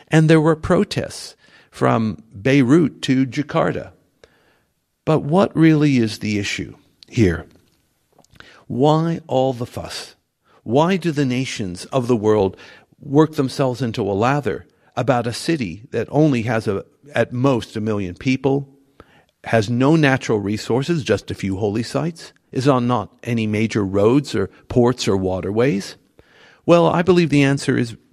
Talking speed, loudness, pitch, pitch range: 145 wpm, -19 LUFS, 130 Hz, 110-145 Hz